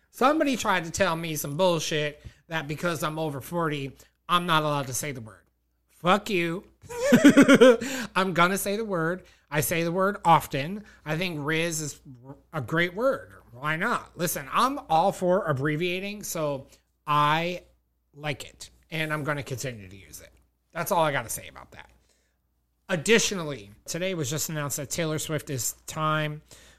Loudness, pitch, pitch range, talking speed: -25 LUFS, 155 Hz, 140-185 Hz, 170 wpm